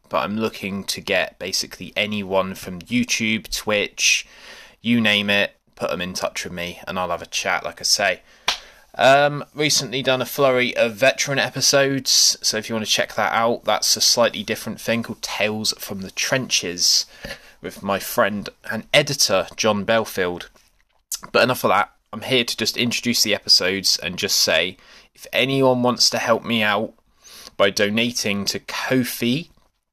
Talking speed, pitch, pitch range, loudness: 170 wpm, 115 Hz, 100-130 Hz, -19 LUFS